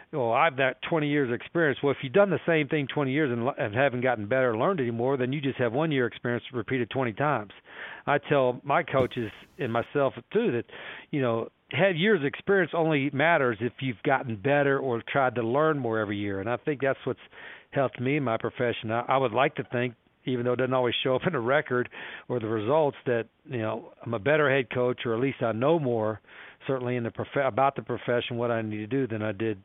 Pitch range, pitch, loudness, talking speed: 120-140 Hz, 130 Hz, -27 LUFS, 245 wpm